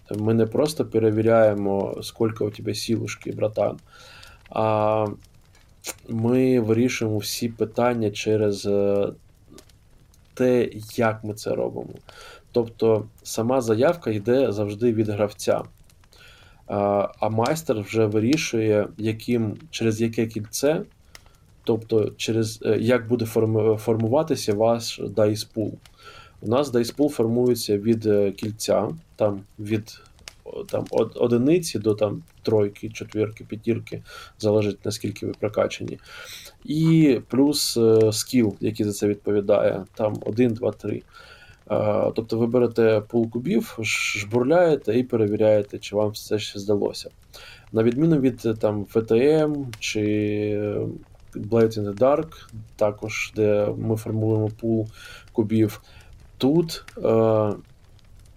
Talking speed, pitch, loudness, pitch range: 110 wpm, 110 Hz, -23 LUFS, 105-120 Hz